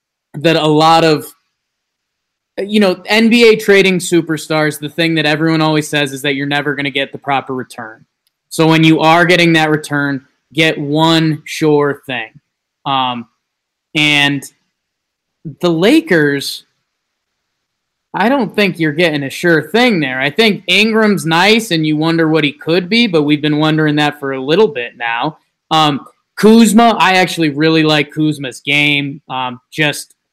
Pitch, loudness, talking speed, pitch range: 155 Hz, -12 LUFS, 160 wpm, 145-170 Hz